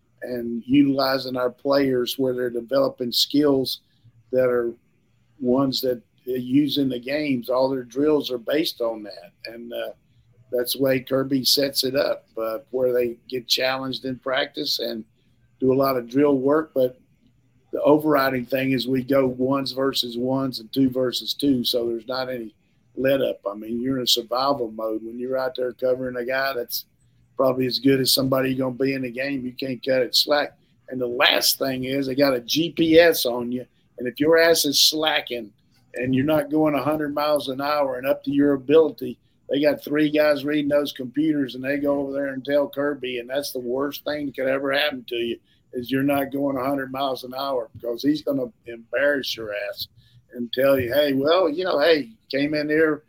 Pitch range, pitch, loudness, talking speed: 125-140 Hz, 130 Hz, -22 LUFS, 200 wpm